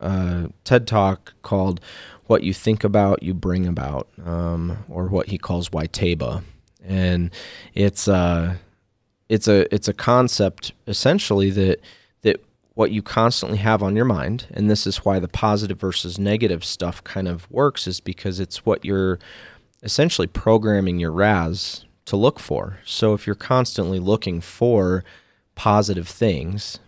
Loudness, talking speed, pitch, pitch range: -21 LUFS, 155 wpm, 95 Hz, 90-105 Hz